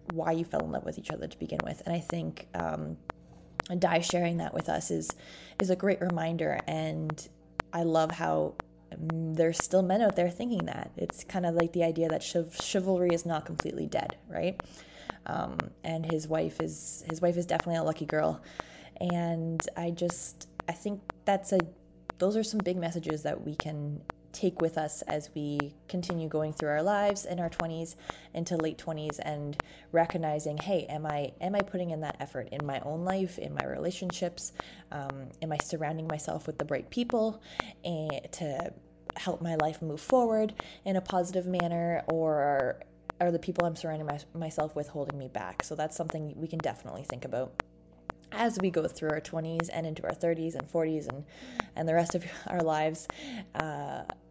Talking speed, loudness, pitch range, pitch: 190 wpm, -32 LUFS, 150-175 Hz, 165 Hz